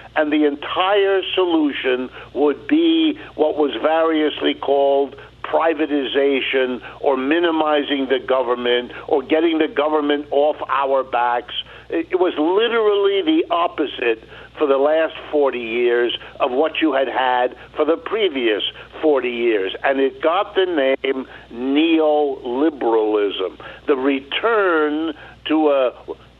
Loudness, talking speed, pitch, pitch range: -19 LUFS, 120 wpm, 150 Hz, 135-165 Hz